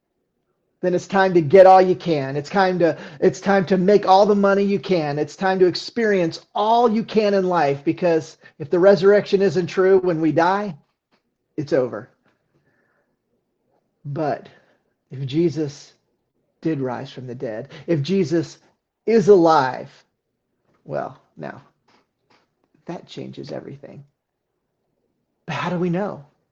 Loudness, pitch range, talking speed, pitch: -18 LUFS, 155-195 Hz, 140 wpm, 180 Hz